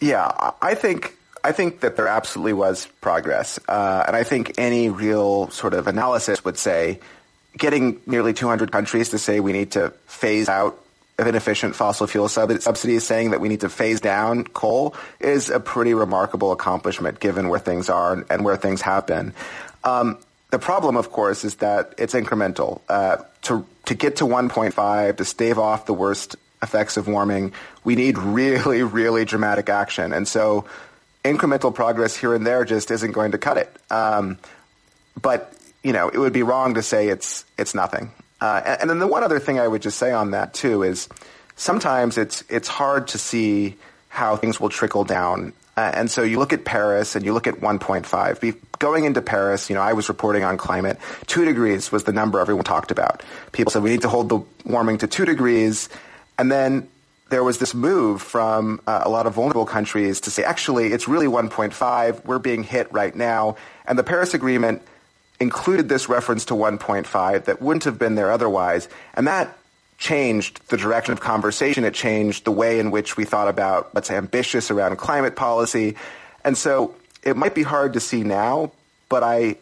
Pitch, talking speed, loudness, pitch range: 110 Hz, 190 wpm, -21 LUFS, 105-120 Hz